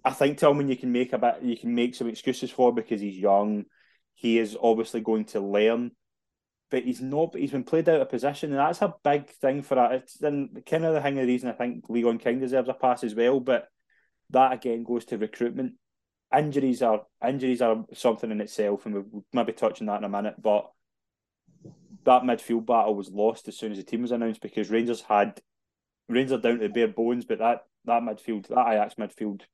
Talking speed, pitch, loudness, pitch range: 215 wpm, 120 Hz, -26 LUFS, 110-130 Hz